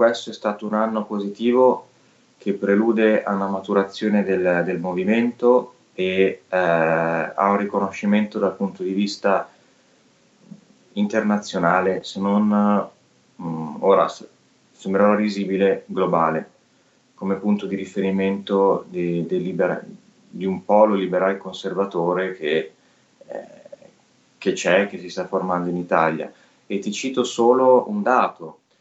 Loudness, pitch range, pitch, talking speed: -21 LUFS, 95-110 Hz, 100 Hz, 125 wpm